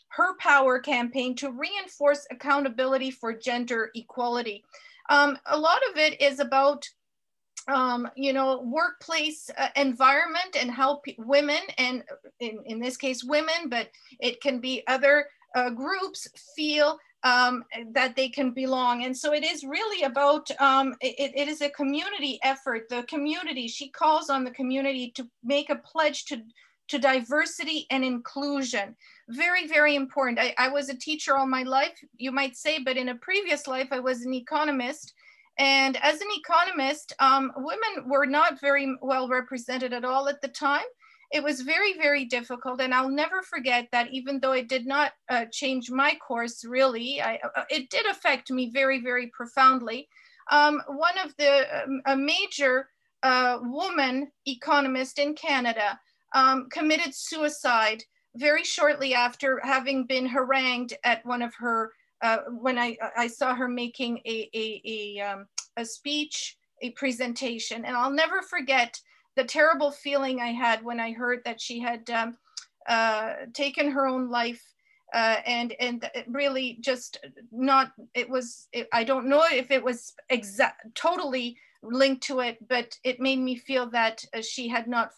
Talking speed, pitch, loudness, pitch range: 165 wpm, 265 Hz, -26 LUFS, 245-290 Hz